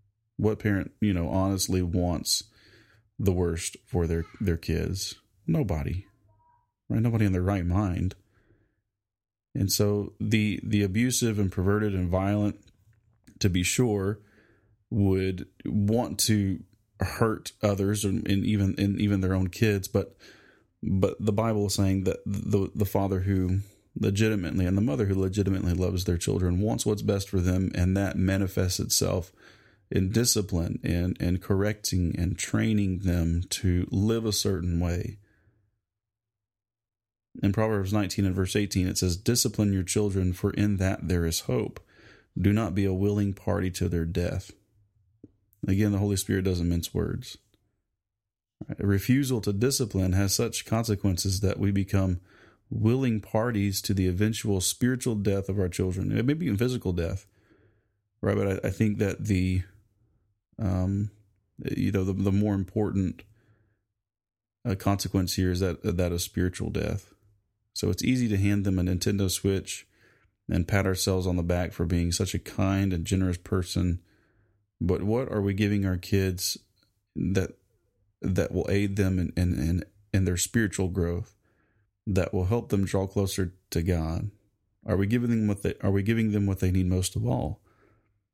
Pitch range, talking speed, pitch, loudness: 95-105 Hz, 160 wpm, 100 Hz, -27 LUFS